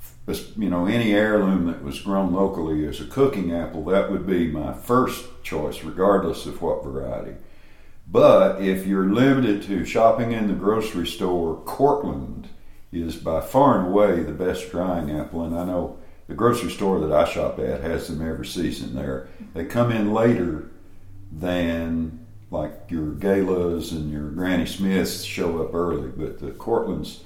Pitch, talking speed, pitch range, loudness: 90 Hz, 165 wpm, 80-100 Hz, -23 LUFS